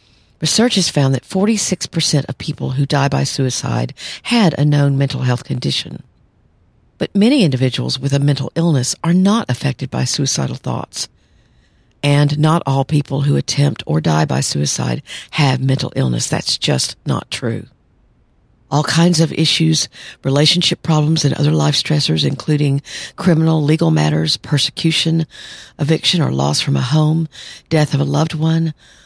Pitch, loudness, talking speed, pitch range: 145 Hz, -16 LUFS, 150 wpm, 130-160 Hz